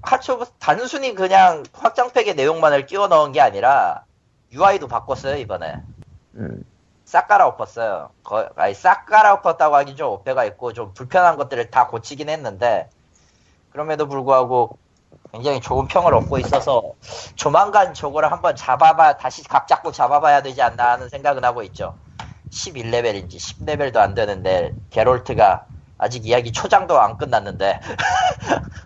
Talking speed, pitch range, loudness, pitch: 320 characters per minute, 125-195 Hz, -18 LUFS, 145 Hz